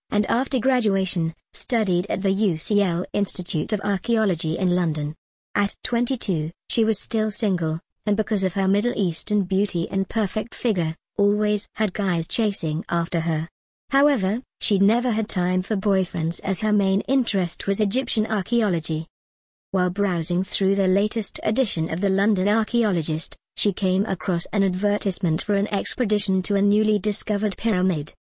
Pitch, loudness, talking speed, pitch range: 200 Hz, -23 LUFS, 150 wpm, 180-215 Hz